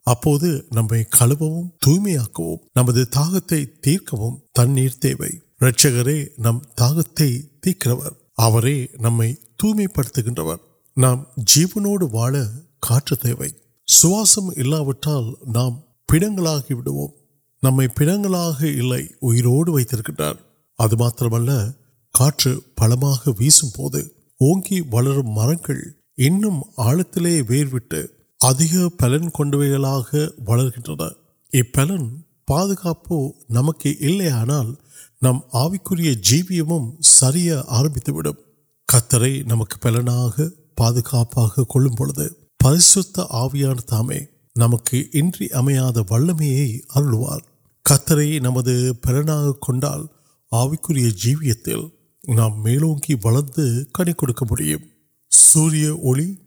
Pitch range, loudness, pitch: 120-155 Hz, -18 LUFS, 135 Hz